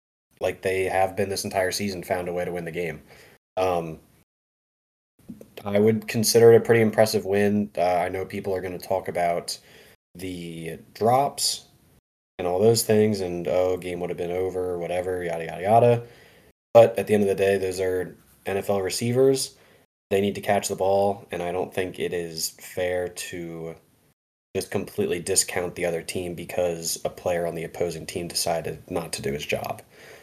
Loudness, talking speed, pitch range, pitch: -24 LUFS, 185 wpm, 85-100 Hz, 95 Hz